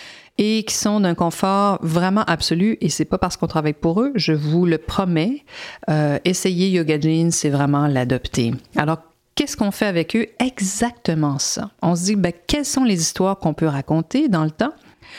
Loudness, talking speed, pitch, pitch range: -20 LUFS, 190 wpm, 175 Hz, 160-215 Hz